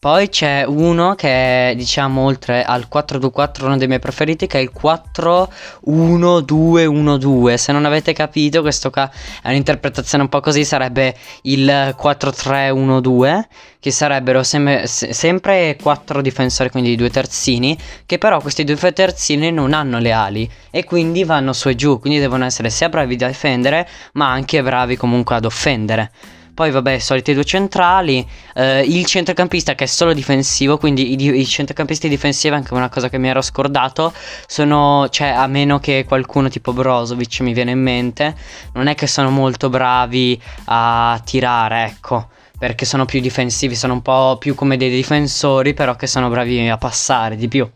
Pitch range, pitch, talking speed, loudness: 125-150 Hz, 135 Hz, 170 wpm, -15 LUFS